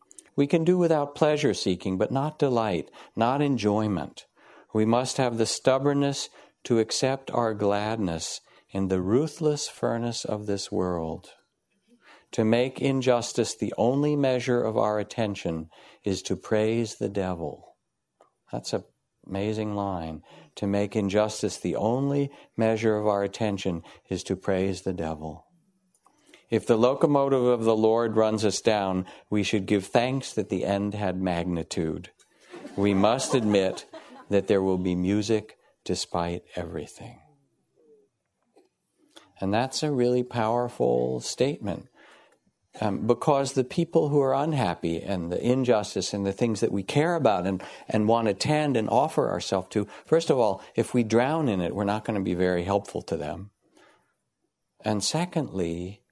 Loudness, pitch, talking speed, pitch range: -26 LUFS, 110 Hz, 150 wpm, 95-130 Hz